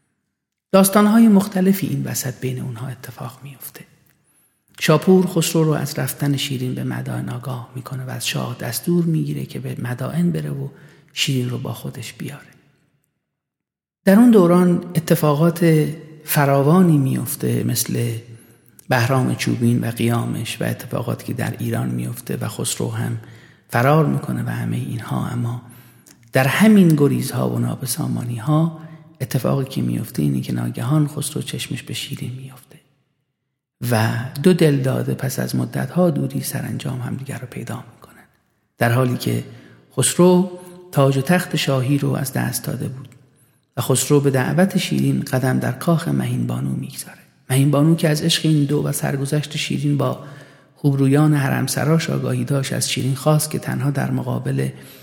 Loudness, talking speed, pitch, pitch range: -19 LUFS, 150 wpm, 135 Hz, 120-155 Hz